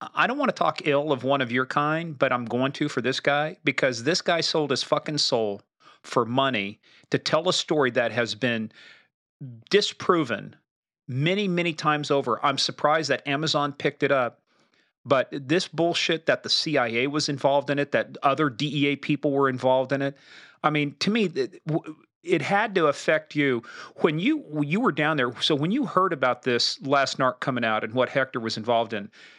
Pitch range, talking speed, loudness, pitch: 130-155 Hz, 195 wpm, -24 LUFS, 145 Hz